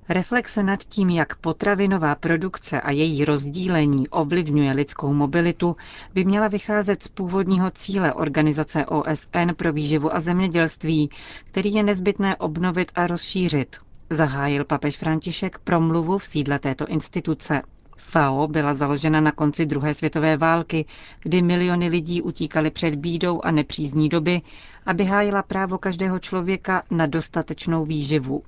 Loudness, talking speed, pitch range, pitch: -22 LUFS, 135 wpm, 155-185 Hz, 165 Hz